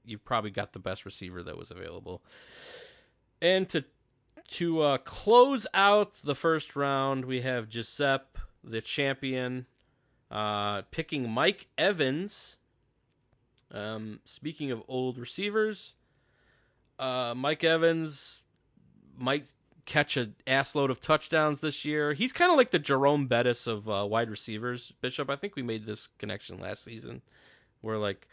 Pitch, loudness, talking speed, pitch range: 135 Hz, -29 LUFS, 140 wpm, 115-155 Hz